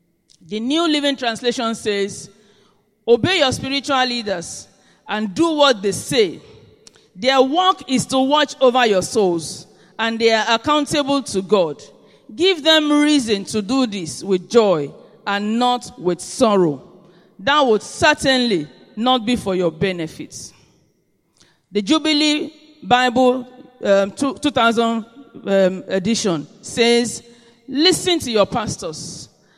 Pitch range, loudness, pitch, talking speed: 195-270 Hz, -18 LUFS, 230 Hz, 120 wpm